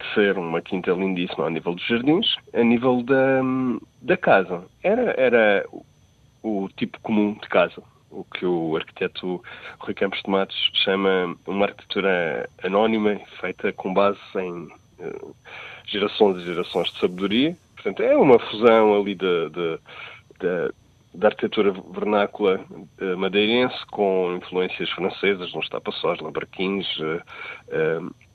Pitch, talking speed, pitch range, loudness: 100 Hz, 135 wpm, 90-115 Hz, -22 LUFS